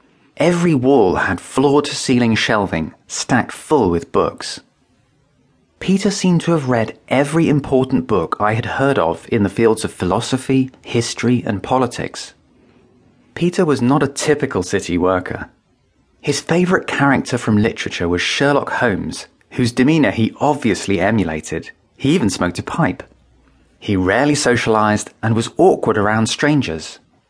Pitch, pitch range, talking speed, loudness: 125 Hz, 105-140 Hz, 140 wpm, -17 LUFS